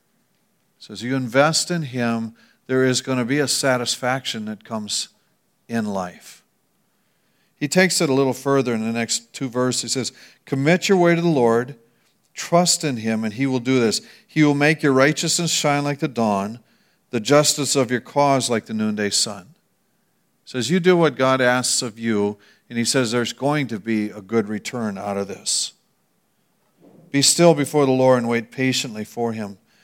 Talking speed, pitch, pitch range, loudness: 190 wpm, 130 Hz, 115-145 Hz, -20 LUFS